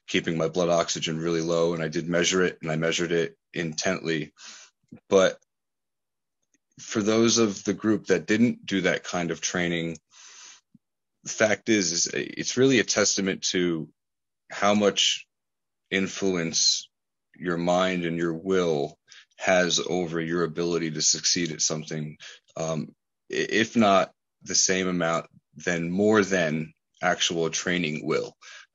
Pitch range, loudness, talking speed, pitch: 80-95 Hz, -25 LUFS, 140 wpm, 85 Hz